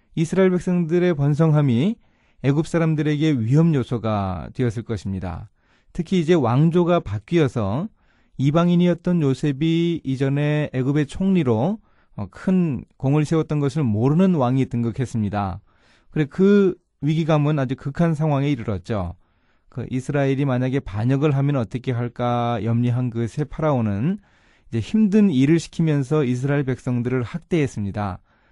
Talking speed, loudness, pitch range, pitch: 310 characters per minute, -21 LUFS, 120-165 Hz, 140 Hz